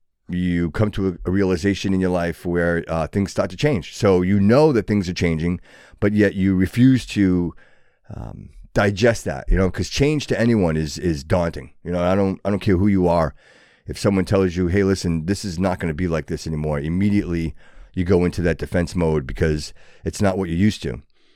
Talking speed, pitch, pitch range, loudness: 215 wpm, 90 Hz, 85-100 Hz, -20 LUFS